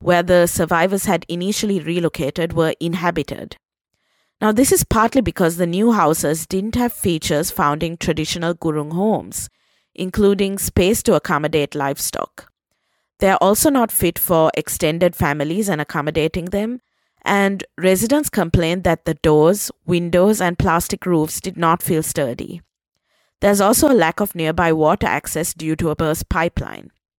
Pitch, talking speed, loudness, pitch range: 175 Hz, 150 wpm, -18 LUFS, 160-200 Hz